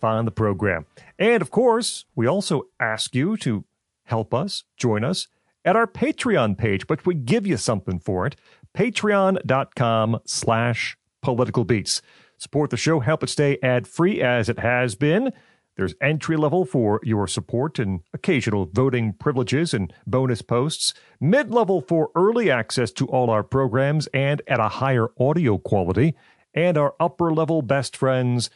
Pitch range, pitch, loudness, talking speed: 115-160 Hz, 130 Hz, -22 LUFS, 150 wpm